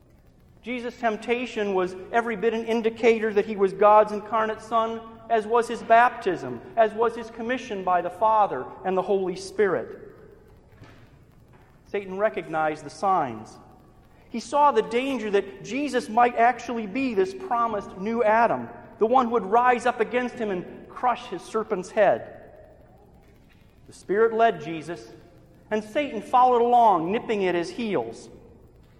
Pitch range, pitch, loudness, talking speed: 210-240 Hz, 225 Hz, -24 LUFS, 145 wpm